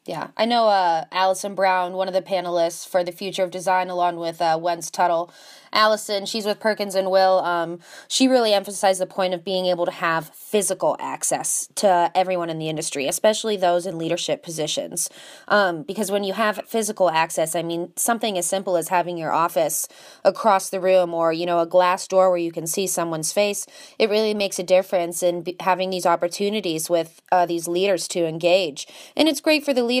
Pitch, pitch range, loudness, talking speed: 185 Hz, 170-205 Hz, -21 LUFS, 205 wpm